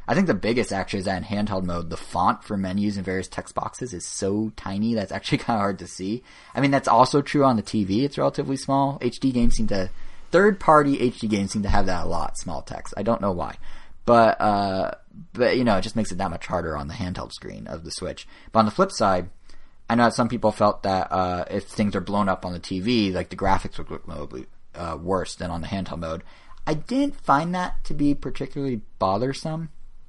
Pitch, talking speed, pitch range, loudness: 105 Hz, 240 wpm, 95-125 Hz, -24 LUFS